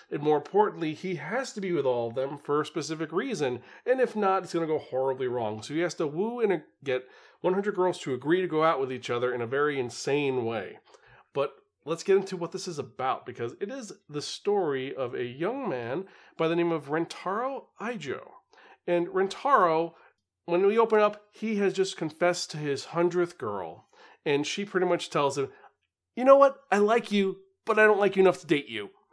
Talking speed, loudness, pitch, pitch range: 215 wpm, -28 LUFS, 175 Hz, 145-200 Hz